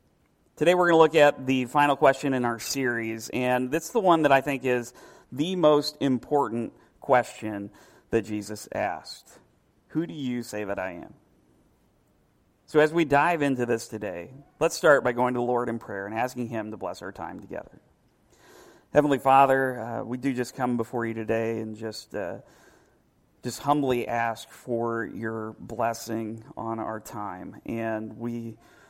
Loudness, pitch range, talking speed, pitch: -26 LUFS, 115-140 Hz, 170 wpm, 125 Hz